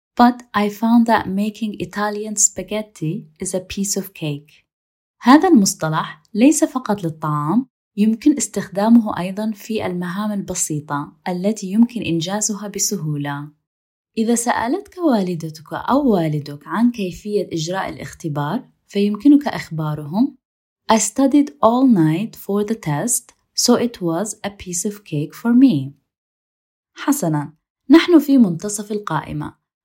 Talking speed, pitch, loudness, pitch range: 115 wpm, 205 Hz, -18 LUFS, 165-230 Hz